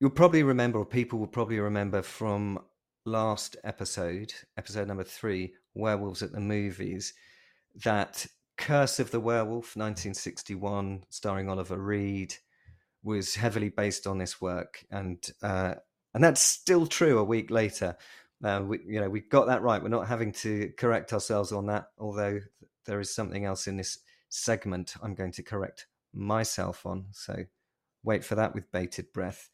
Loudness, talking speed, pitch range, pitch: -30 LUFS, 160 wpm, 95-110 Hz, 105 Hz